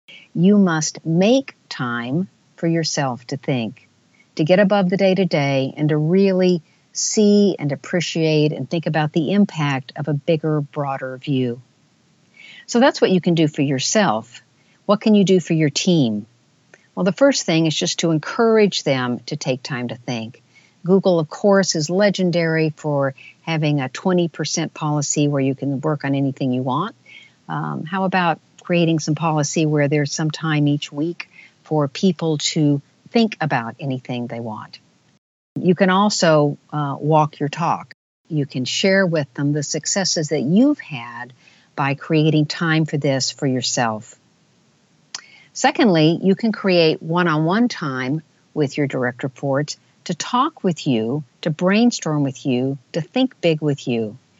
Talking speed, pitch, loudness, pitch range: 160 wpm, 155 Hz, -19 LUFS, 140-180 Hz